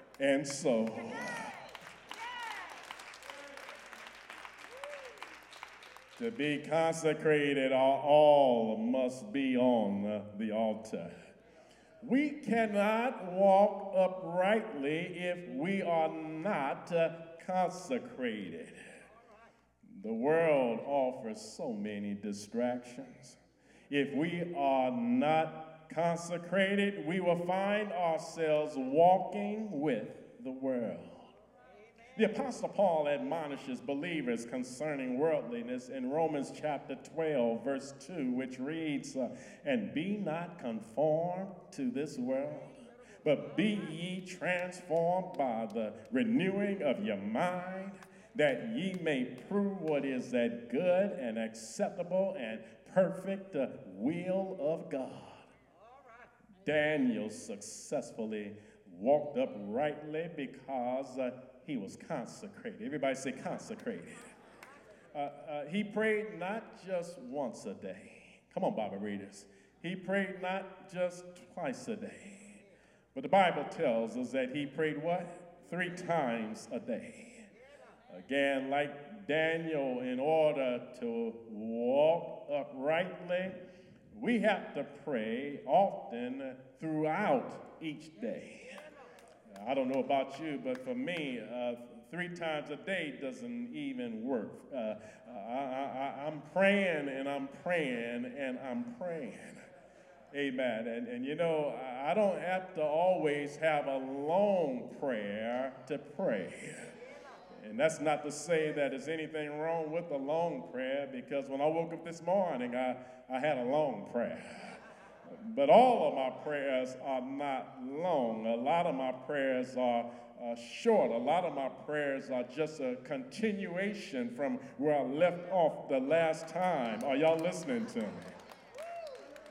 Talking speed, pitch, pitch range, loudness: 120 wpm, 165 Hz, 135-200 Hz, -34 LUFS